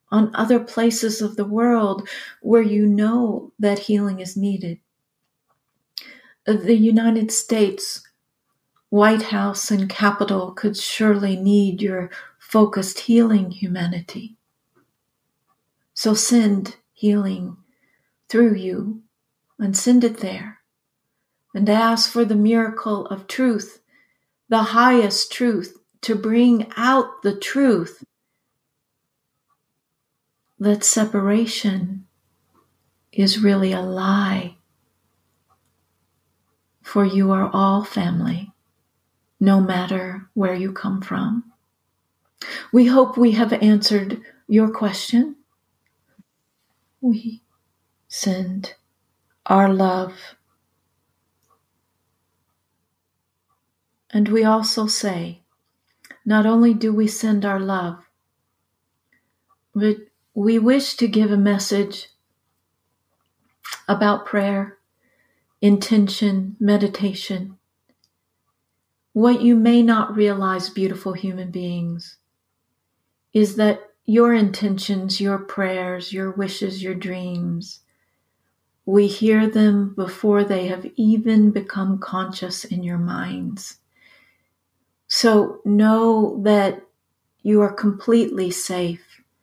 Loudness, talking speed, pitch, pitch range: -19 LUFS, 95 wpm, 205 Hz, 190-220 Hz